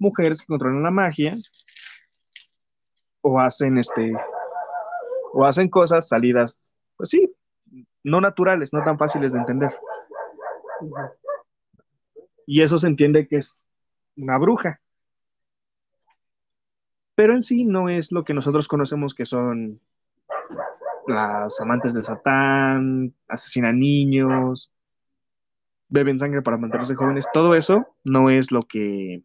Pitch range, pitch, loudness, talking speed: 125-175 Hz, 145 Hz, -20 LUFS, 115 wpm